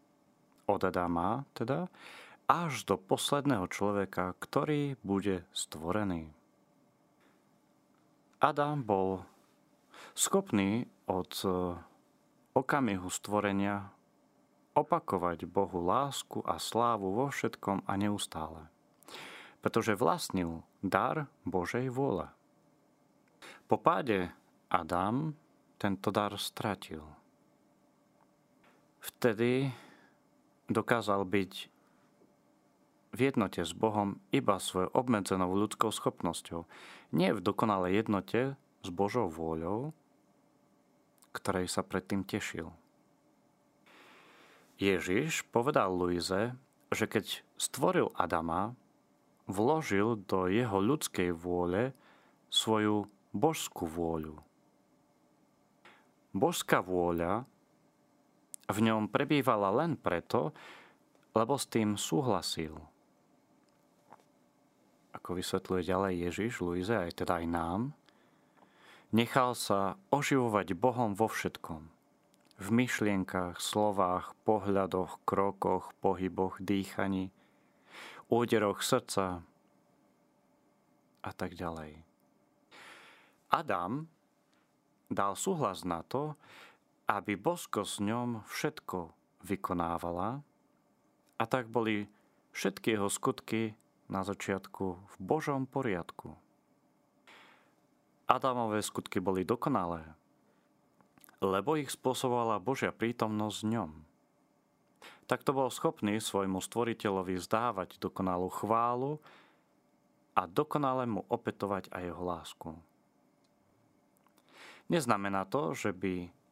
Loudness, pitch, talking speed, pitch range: -33 LUFS, 100 Hz, 85 wpm, 95-120 Hz